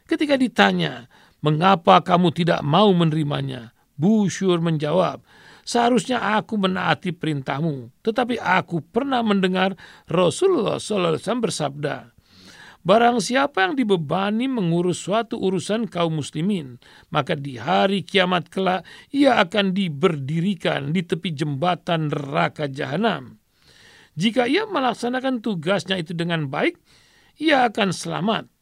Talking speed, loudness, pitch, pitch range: 110 wpm, -21 LUFS, 185 Hz, 160-225 Hz